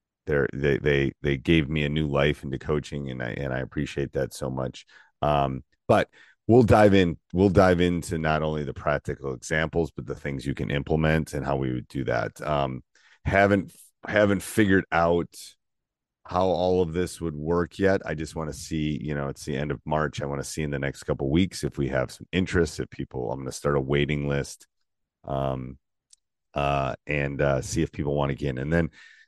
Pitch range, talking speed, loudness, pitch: 70-85 Hz, 215 wpm, -26 LUFS, 75 Hz